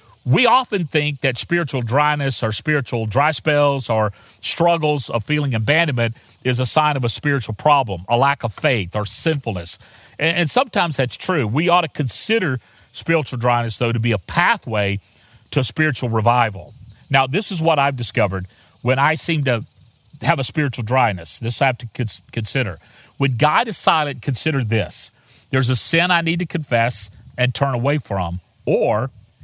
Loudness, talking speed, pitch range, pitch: -19 LUFS, 170 wpm, 115-150 Hz, 125 Hz